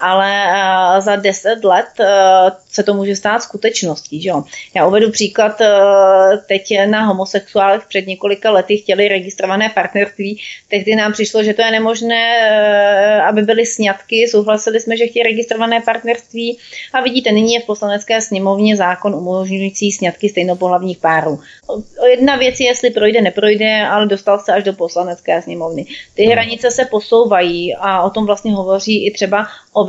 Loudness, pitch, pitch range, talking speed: -13 LUFS, 205 Hz, 195-225 Hz, 150 wpm